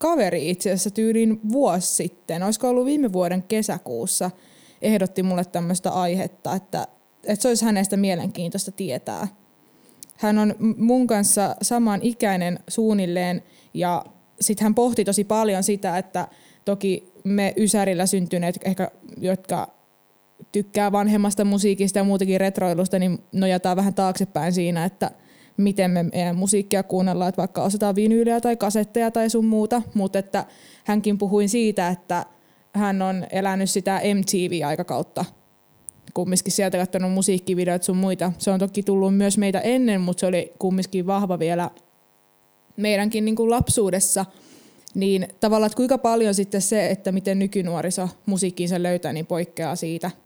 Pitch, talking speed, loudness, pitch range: 195 Hz, 140 wpm, -22 LUFS, 180-210 Hz